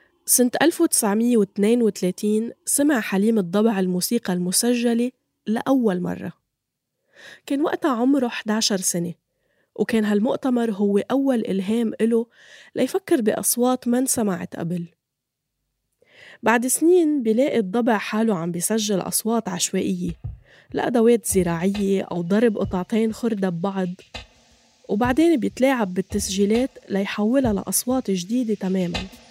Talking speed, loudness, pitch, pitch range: 100 wpm, -21 LUFS, 220 Hz, 190-245 Hz